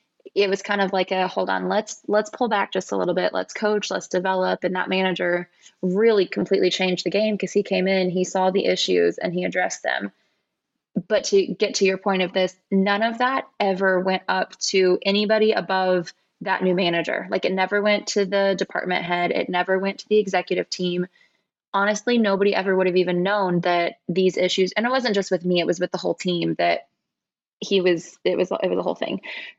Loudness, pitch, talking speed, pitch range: -22 LUFS, 190 Hz, 215 wpm, 180-205 Hz